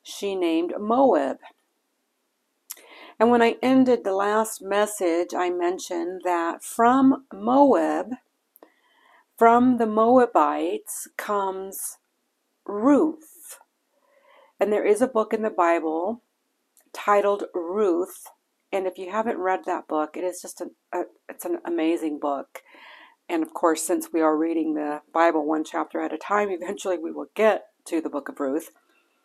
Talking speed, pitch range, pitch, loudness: 140 wpm, 170-255 Hz, 200 Hz, -23 LUFS